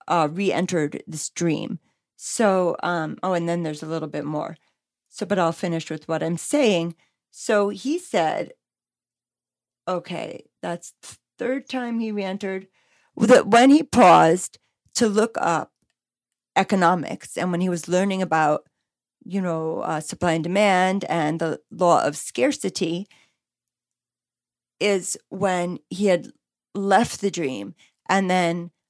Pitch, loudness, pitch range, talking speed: 175 Hz, -22 LUFS, 160-200 Hz, 140 wpm